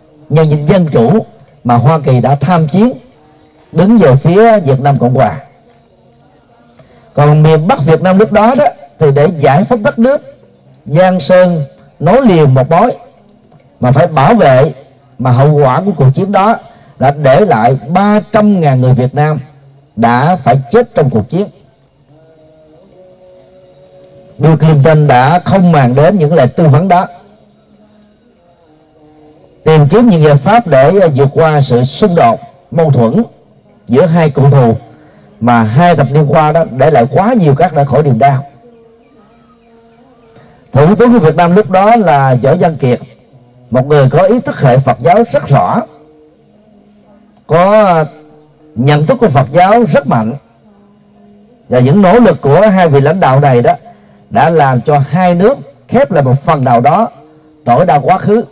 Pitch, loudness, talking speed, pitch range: 155 Hz, -8 LUFS, 165 wpm, 140-195 Hz